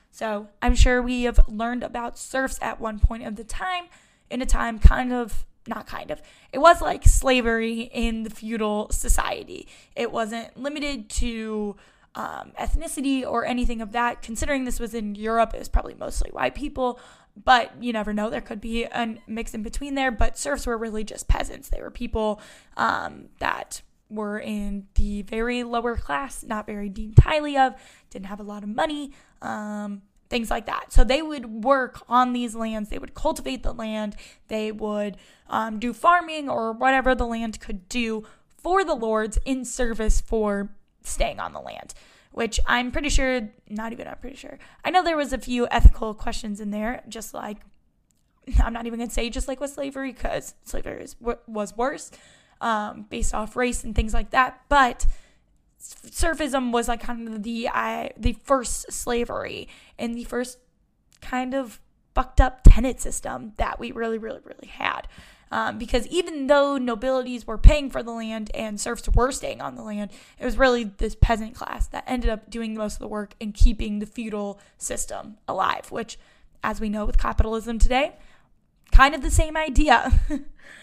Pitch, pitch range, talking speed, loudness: 235 Hz, 220-260 Hz, 185 wpm, -25 LUFS